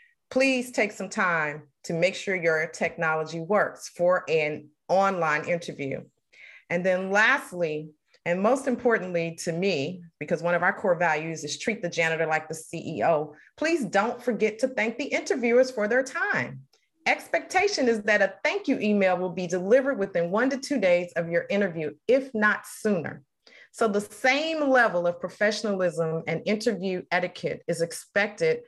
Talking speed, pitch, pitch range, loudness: 160 wpm, 195 Hz, 170-240 Hz, -26 LUFS